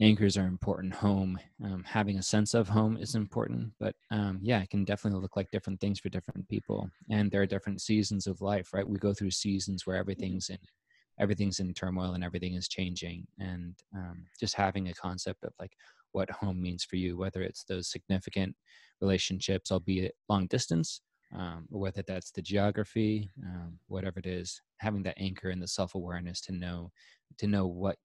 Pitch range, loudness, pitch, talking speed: 90-100 Hz, -33 LUFS, 95 Hz, 190 wpm